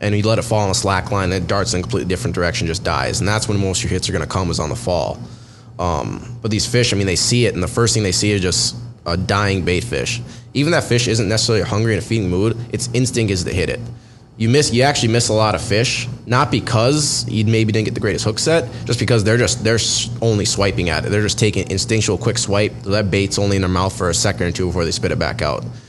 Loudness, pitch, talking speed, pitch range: -17 LUFS, 110 Hz, 285 wpm, 100-120 Hz